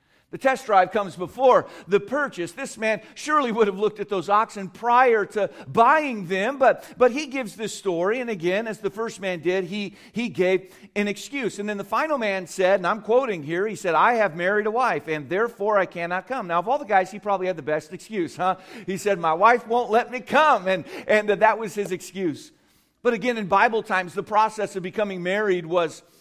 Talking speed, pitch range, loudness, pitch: 225 wpm, 185-230 Hz, -23 LUFS, 205 Hz